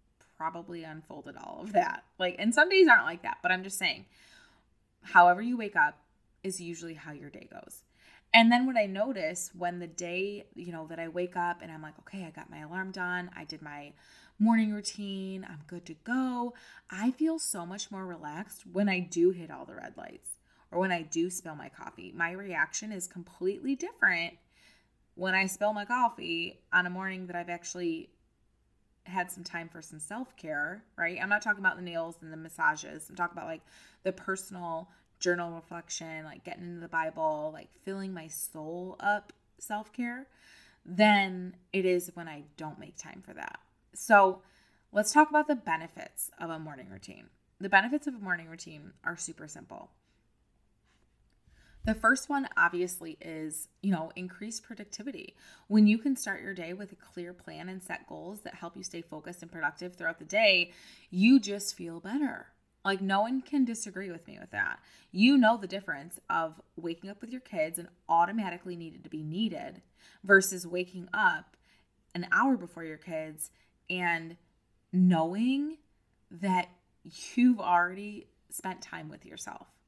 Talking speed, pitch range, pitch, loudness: 180 wpm, 170-210 Hz, 185 Hz, -30 LUFS